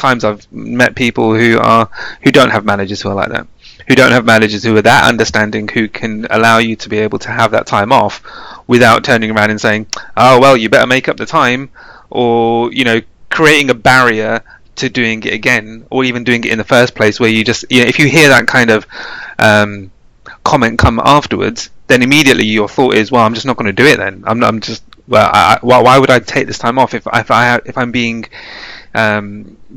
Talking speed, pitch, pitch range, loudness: 235 wpm, 115 Hz, 110-125 Hz, -10 LUFS